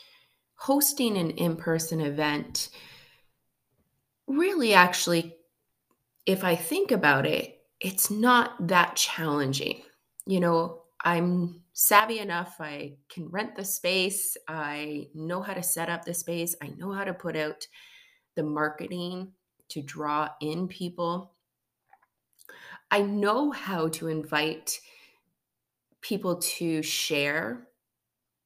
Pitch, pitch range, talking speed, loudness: 175 Hz, 160-200 Hz, 115 wpm, -27 LUFS